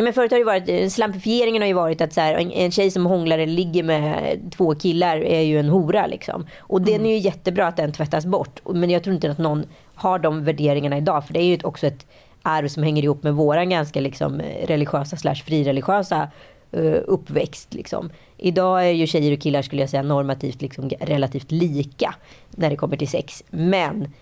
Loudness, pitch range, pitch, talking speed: -21 LUFS, 150-185 Hz, 160 Hz, 205 wpm